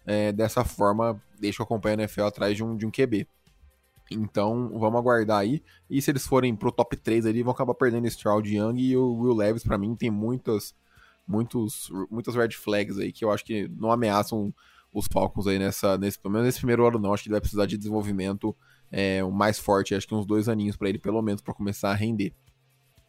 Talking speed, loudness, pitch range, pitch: 225 wpm, -26 LUFS, 100-120 Hz, 110 Hz